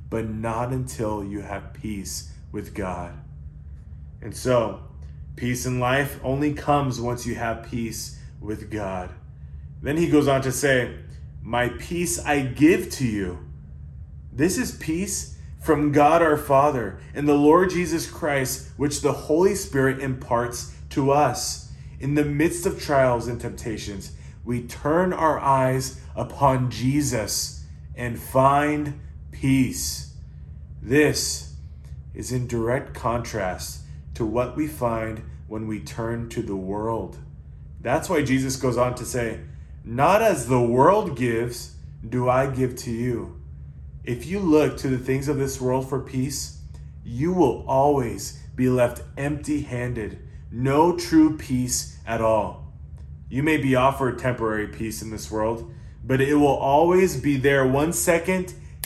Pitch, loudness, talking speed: 120 Hz, -23 LUFS, 145 wpm